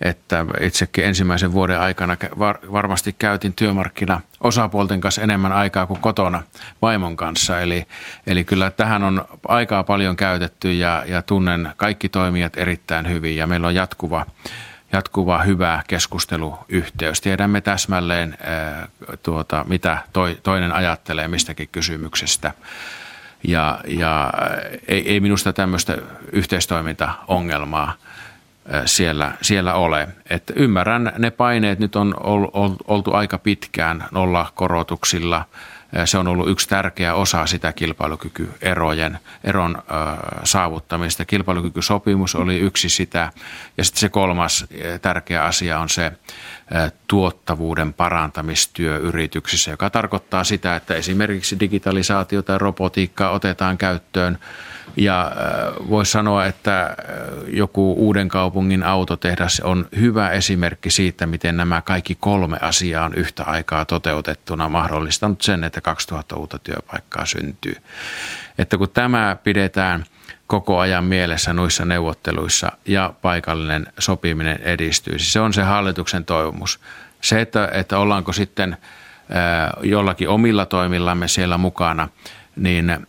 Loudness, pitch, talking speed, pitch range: -19 LUFS, 90 Hz, 115 wpm, 85-100 Hz